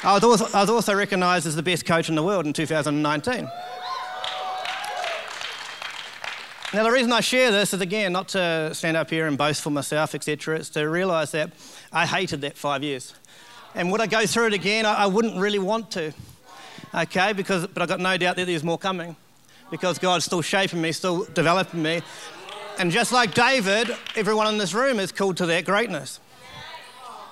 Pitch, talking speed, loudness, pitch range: 185 Hz, 185 wpm, -23 LUFS, 160-210 Hz